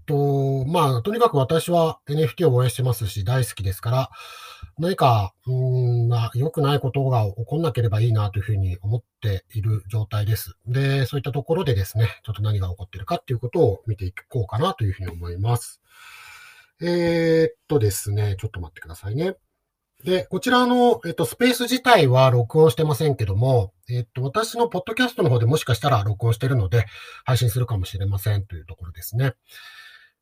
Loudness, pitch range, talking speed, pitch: -22 LUFS, 105-155 Hz, 405 characters per minute, 125 Hz